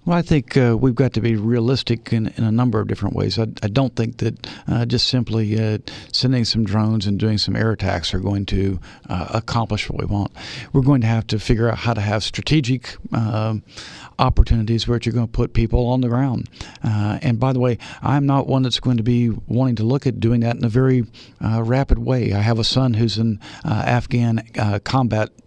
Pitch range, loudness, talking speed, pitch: 110-125 Hz, -20 LUFS, 230 wpm, 115 Hz